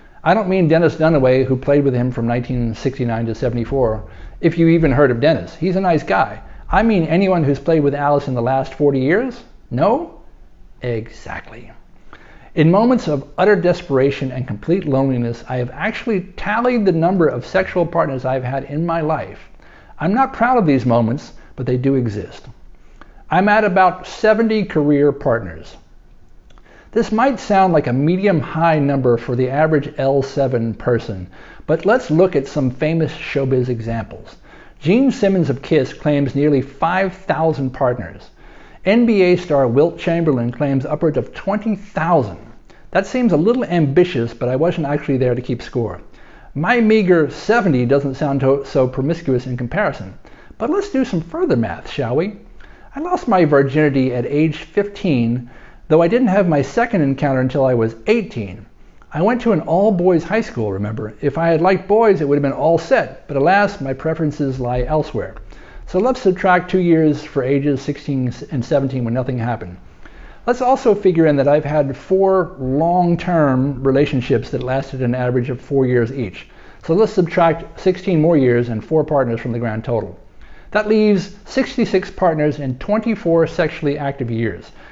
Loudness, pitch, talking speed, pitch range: -17 LUFS, 145 Hz, 170 wpm, 130-180 Hz